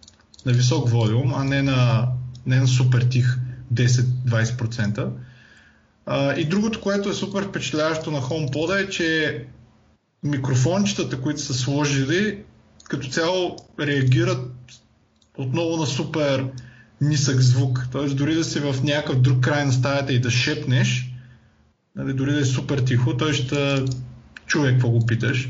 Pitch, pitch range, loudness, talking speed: 130 Hz, 125-150 Hz, -22 LUFS, 140 wpm